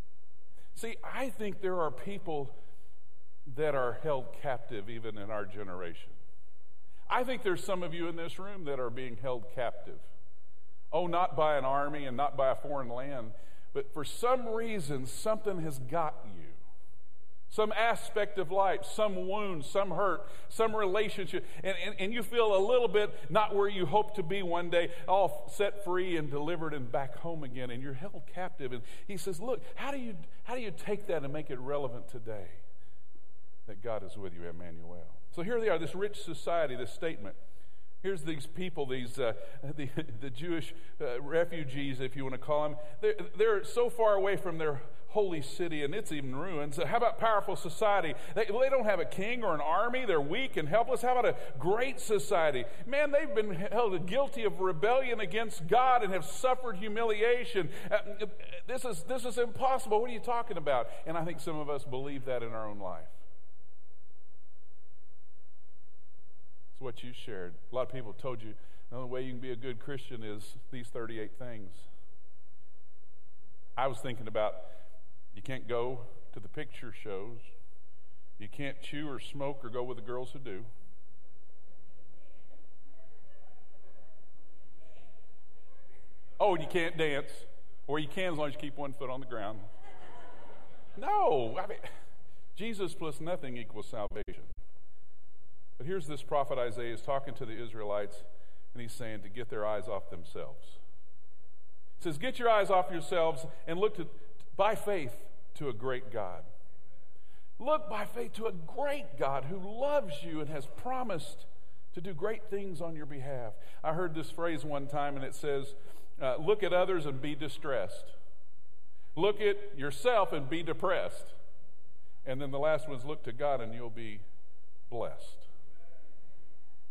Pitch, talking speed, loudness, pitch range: 145 Hz, 175 wpm, -34 LUFS, 115-195 Hz